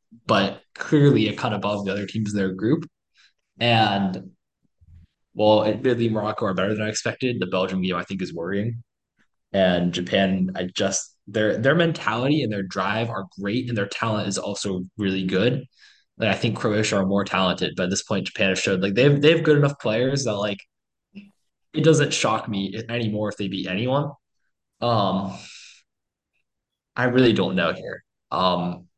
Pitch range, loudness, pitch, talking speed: 95-120 Hz, -22 LUFS, 105 Hz, 175 wpm